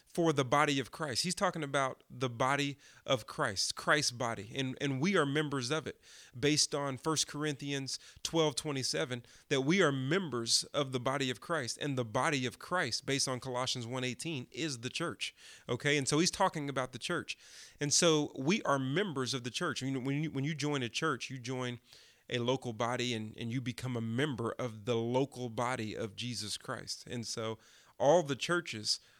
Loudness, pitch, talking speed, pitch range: -34 LUFS, 135 Hz, 195 wpm, 125-150 Hz